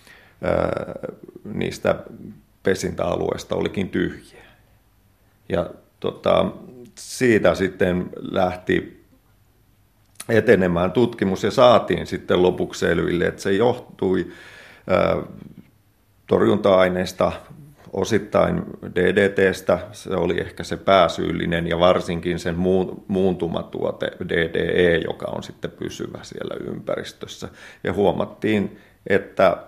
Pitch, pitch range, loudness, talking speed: 95 Hz, 90-105 Hz, -21 LUFS, 85 wpm